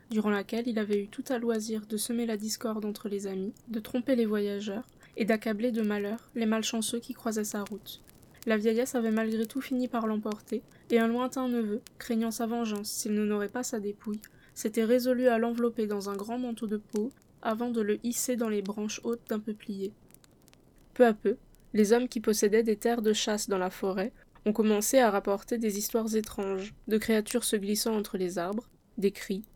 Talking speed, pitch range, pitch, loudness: 205 wpm, 210-235 Hz, 220 Hz, -30 LUFS